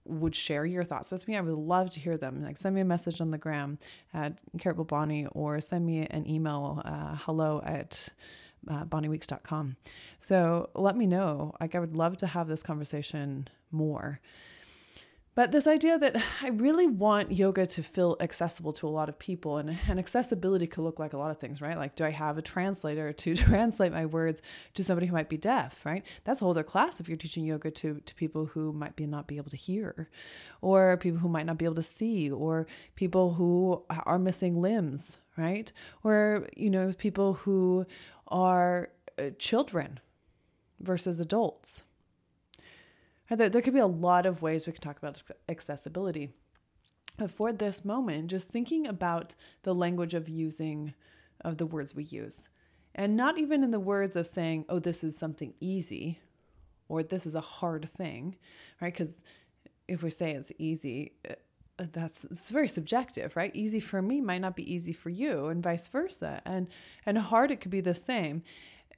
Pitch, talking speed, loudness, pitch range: 170 Hz, 190 wpm, -31 LUFS, 155-190 Hz